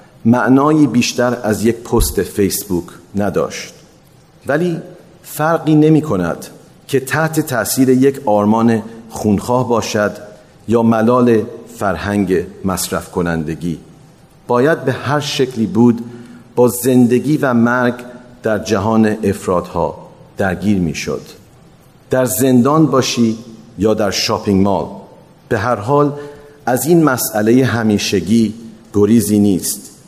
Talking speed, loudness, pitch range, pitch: 110 wpm, -15 LUFS, 105-135 Hz, 120 Hz